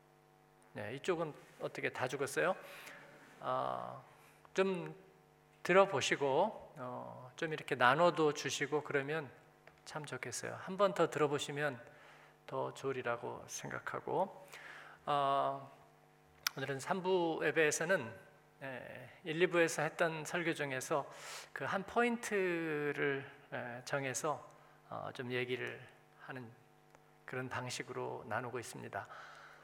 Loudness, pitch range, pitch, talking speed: -37 LUFS, 130-165 Hz, 150 Hz, 220 characters per minute